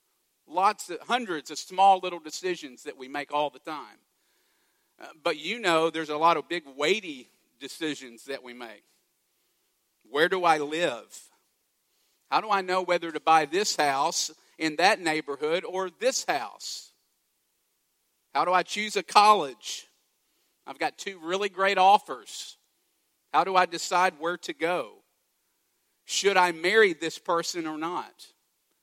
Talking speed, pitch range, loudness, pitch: 150 wpm, 160-210 Hz, -26 LUFS, 180 Hz